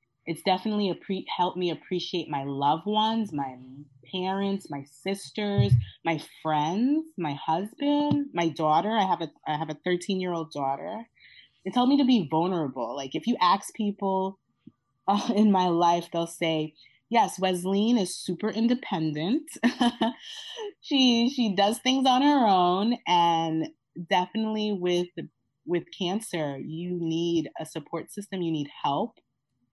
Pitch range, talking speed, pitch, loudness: 160-215 Hz, 145 wpm, 180 Hz, -27 LUFS